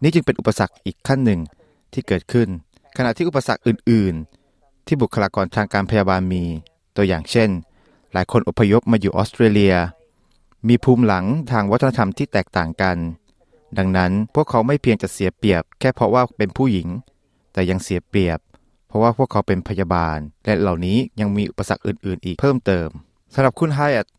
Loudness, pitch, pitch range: -19 LUFS, 100 Hz, 90-120 Hz